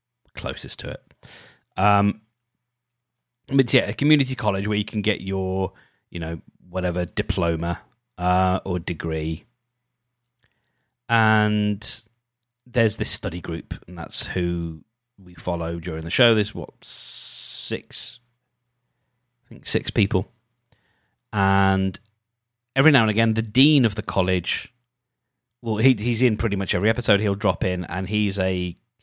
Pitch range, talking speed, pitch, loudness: 95-120 Hz, 135 wpm, 105 Hz, -23 LUFS